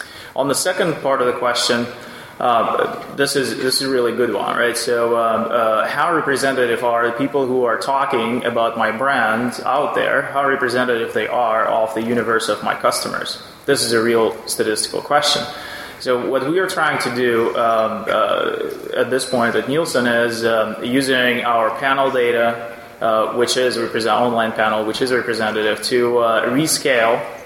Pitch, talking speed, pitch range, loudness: 120 Hz, 175 wpm, 115-135 Hz, -18 LUFS